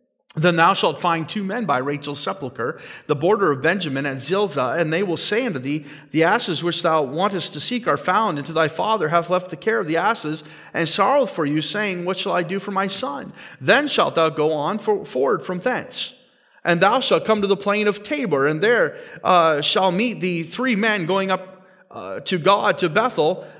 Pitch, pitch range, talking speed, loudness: 185 Hz, 160-210 Hz, 220 wpm, -19 LUFS